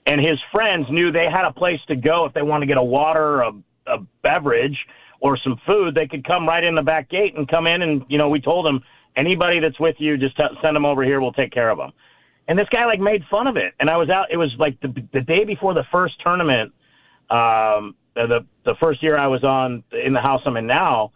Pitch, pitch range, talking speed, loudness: 155 Hz, 135-170 Hz, 260 wpm, -19 LUFS